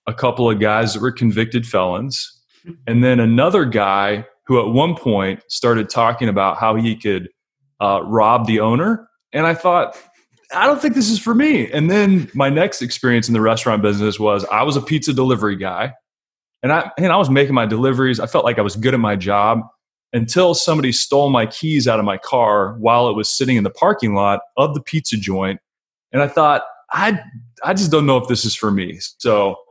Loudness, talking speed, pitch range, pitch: -17 LUFS, 210 wpm, 110-150 Hz, 120 Hz